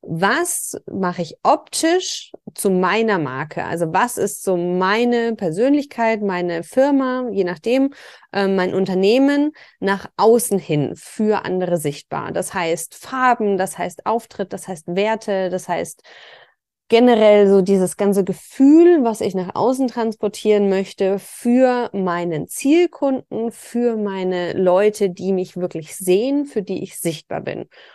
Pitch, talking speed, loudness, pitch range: 200 Hz, 135 wpm, -18 LUFS, 185-240 Hz